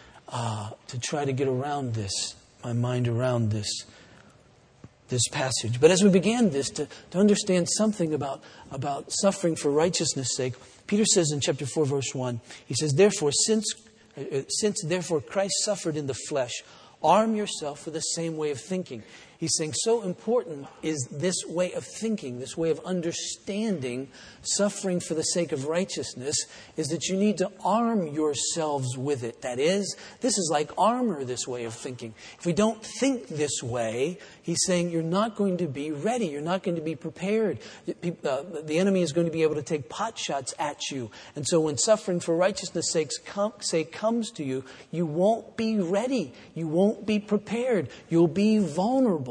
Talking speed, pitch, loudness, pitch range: 180 wpm, 165 Hz, -27 LUFS, 140-200 Hz